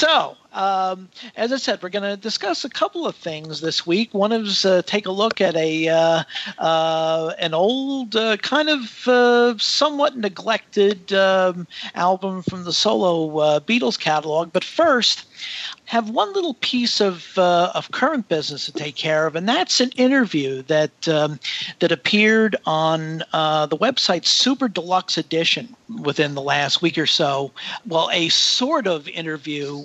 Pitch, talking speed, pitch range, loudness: 185 Hz, 165 wpm, 160-230 Hz, -19 LUFS